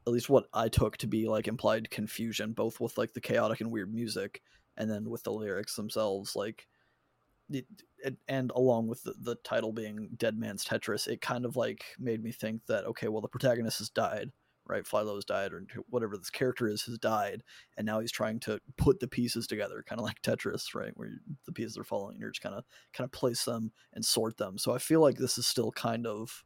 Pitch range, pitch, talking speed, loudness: 110-120 Hz, 115 Hz, 235 wpm, -33 LUFS